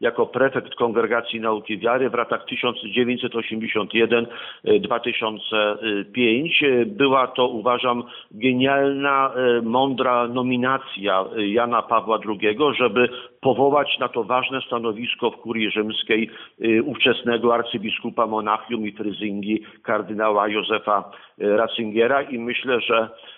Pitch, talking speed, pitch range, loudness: 115 Hz, 100 wpm, 110-125 Hz, -21 LUFS